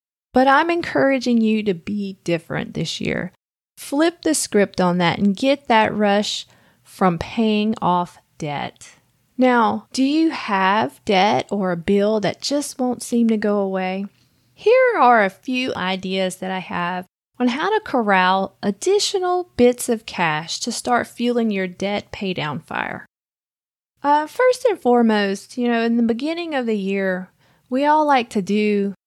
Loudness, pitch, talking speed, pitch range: -19 LUFS, 220 Hz, 160 wpm, 190-260 Hz